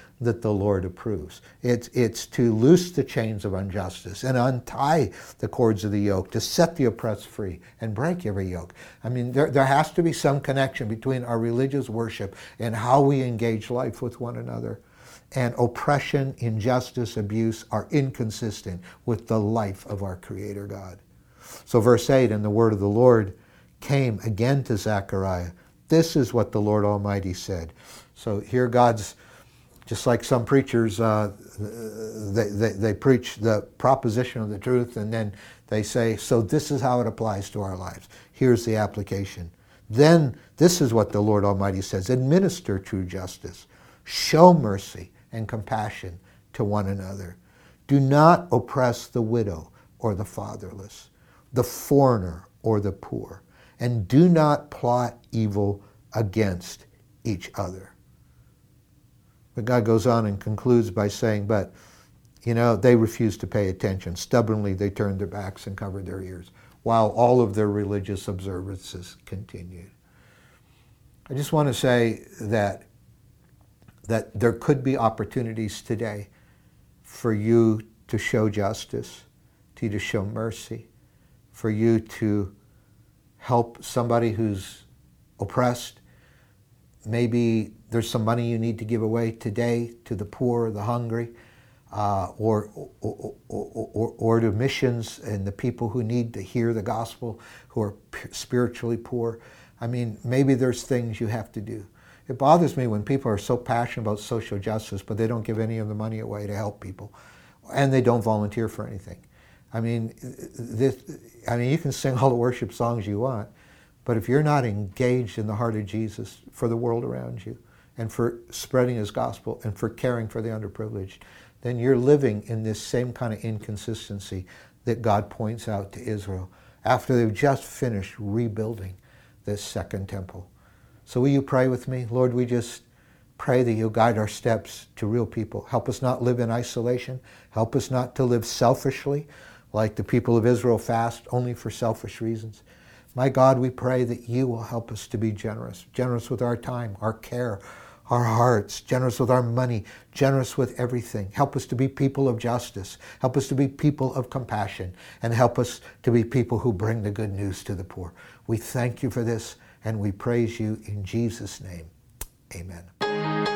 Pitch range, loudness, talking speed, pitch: 105-125 Hz, -25 LUFS, 170 wpm, 115 Hz